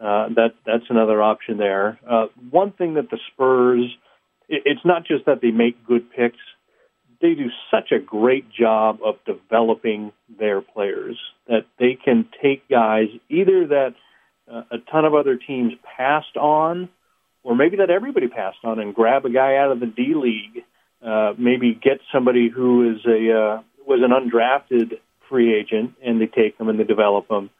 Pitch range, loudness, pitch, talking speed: 110-140 Hz, -19 LUFS, 120 Hz, 180 wpm